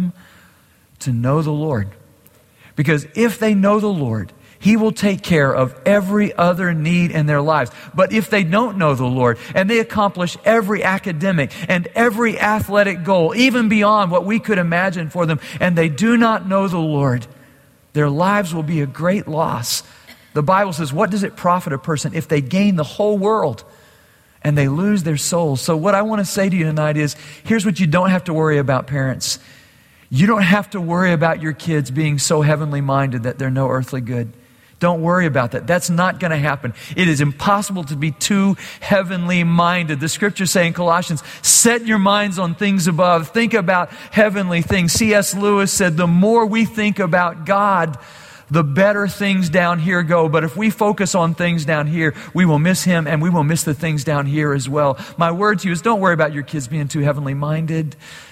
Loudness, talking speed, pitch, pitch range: -17 LUFS, 205 wpm, 170 Hz, 150-195 Hz